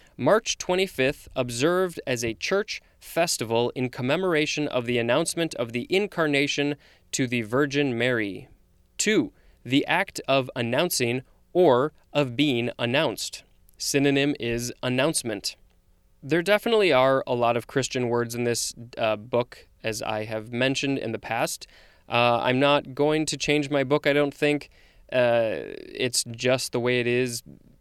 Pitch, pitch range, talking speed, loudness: 125 Hz, 120-145 Hz, 145 wpm, -25 LUFS